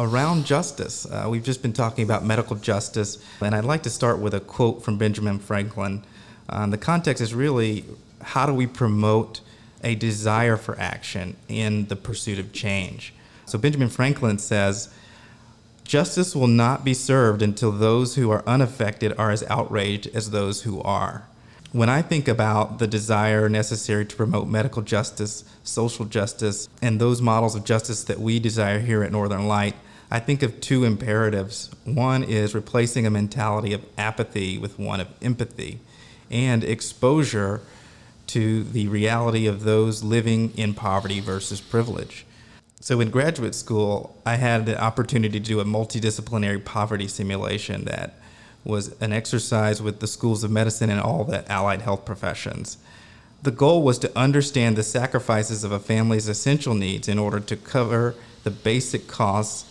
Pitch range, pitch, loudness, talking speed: 105-120 Hz, 110 Hz, -23 LUFS, 160 wpm